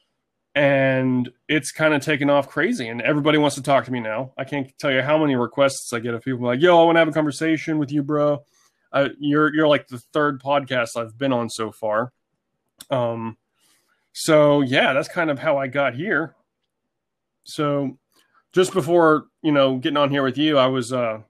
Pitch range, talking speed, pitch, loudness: 125-150 Hz, 205 wpm, 140 Hz, -20 LUFS